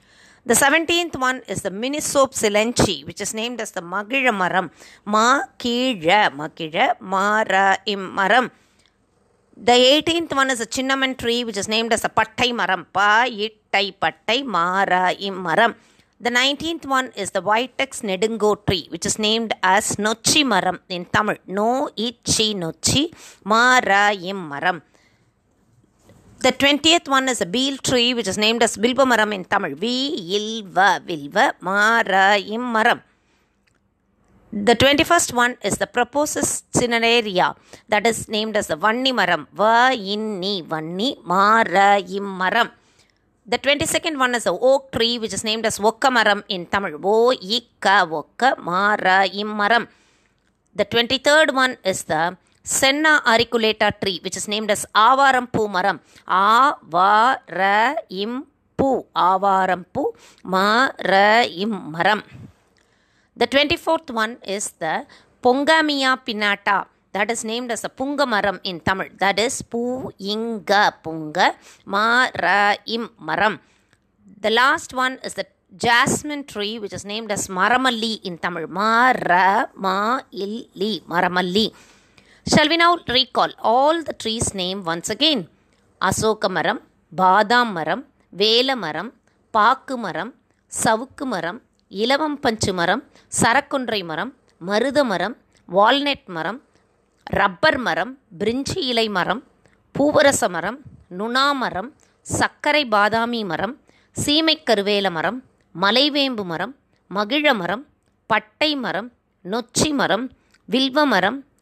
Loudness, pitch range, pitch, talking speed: -19 LUFS, 195-255 Hz, 220 Hz, 120 wpm